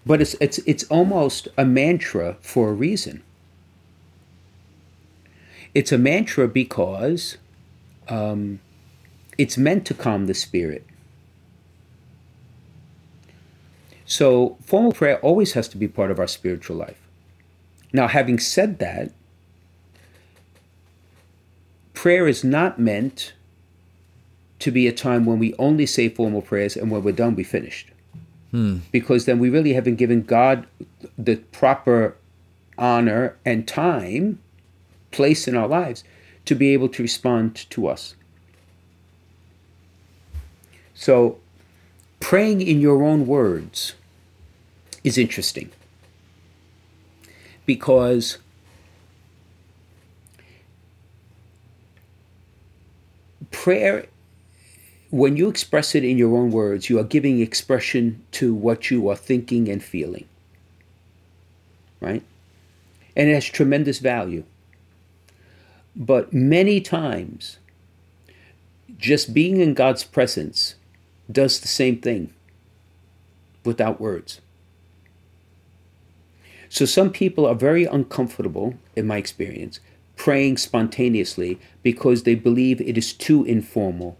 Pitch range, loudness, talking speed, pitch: 90-125 Hz, -20 LUFS, 105 wpm, 100 Hz